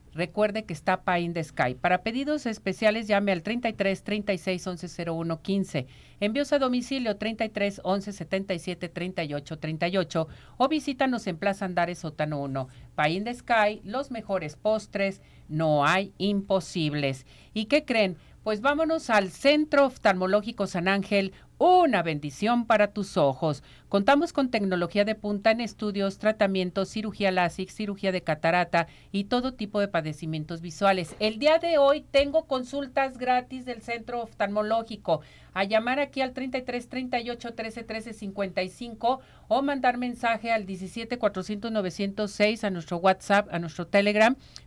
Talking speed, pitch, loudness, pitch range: 140 wpm, 205 Hz, -27 LUFS, 180-235 Hz